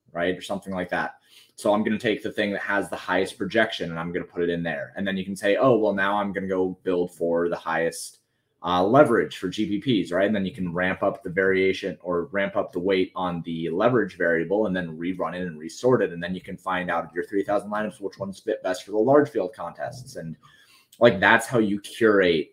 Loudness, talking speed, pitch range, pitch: -24 LUFS, 255 wpm, 85-100 Hz, 95 Hz